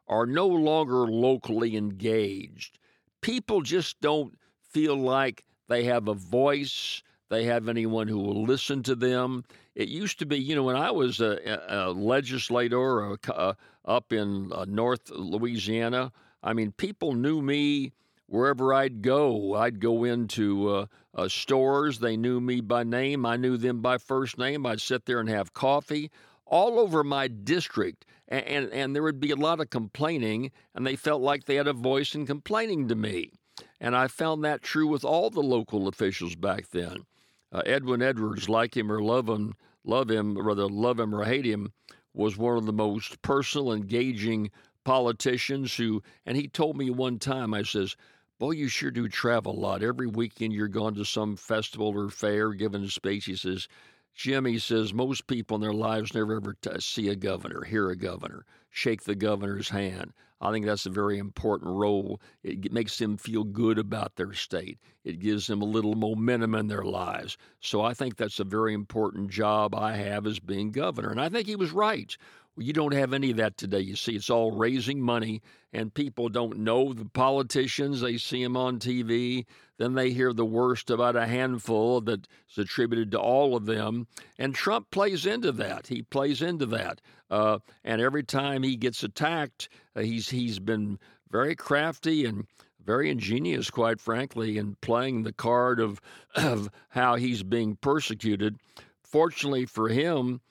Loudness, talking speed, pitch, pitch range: -28 LUFS, 180 wpm, 120 Hz, 105-135 Hz